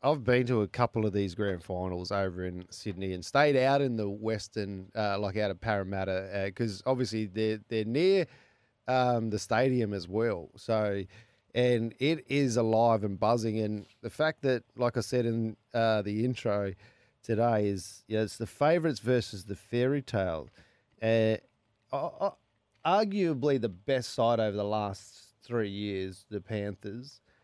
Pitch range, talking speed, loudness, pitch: 100-125 Hz, 165 wpm, -30 LUFS, 110 Hz